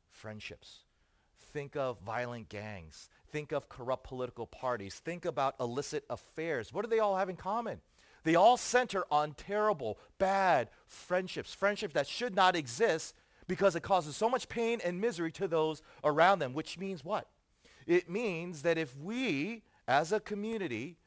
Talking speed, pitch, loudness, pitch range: 160 wpm, 170 Hz, -33 LUFS, 135-205 Hz